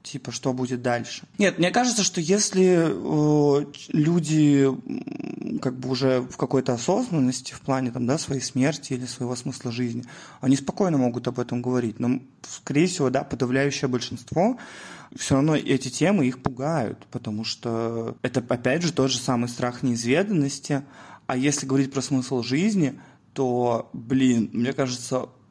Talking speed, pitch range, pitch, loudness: 155 wpm, 125-150 Hz, 135 Hz, -24 LUFS